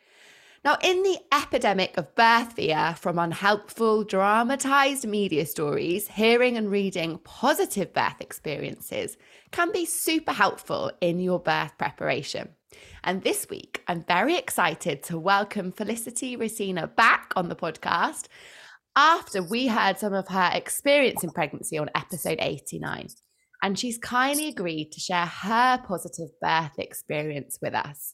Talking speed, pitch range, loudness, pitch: 135 wpm, 175-270 Hz, -25 LUFS, 210 Hz